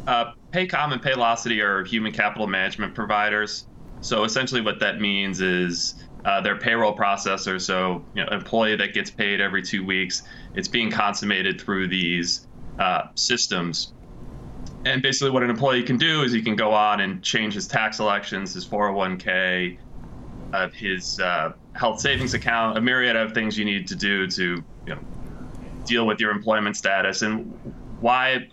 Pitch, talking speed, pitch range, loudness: 105 Hz, 170 wpm, 95-120 Hz, -23 LUFS